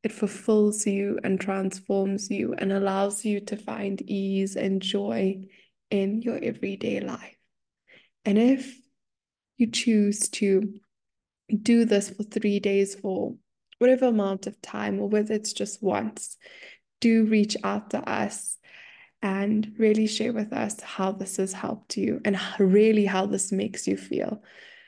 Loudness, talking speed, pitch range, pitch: -26 LUFS, 145 wpm, 195-225 Hz, 210 Hz